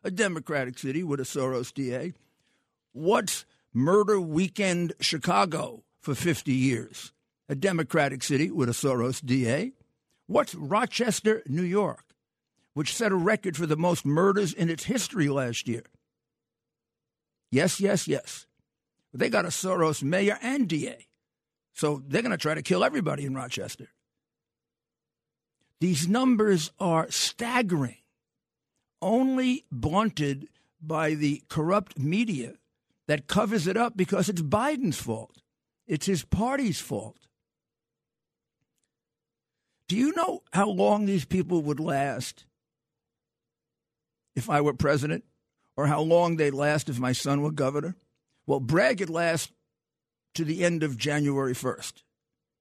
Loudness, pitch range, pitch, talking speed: -27 LUFS, 140-195 Hz, 160 Hz, 130 wpm